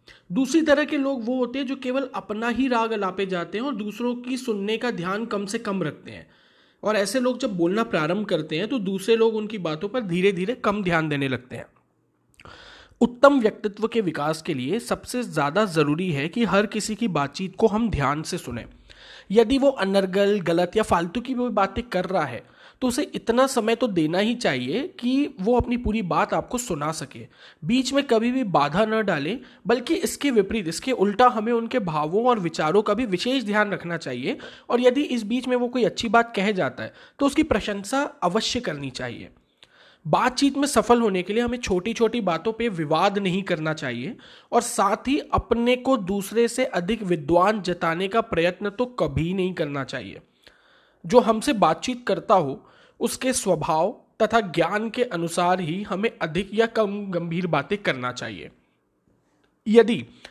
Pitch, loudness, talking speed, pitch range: 210 Hz, -23 LUFS, 190 wpm, 180-240 Hz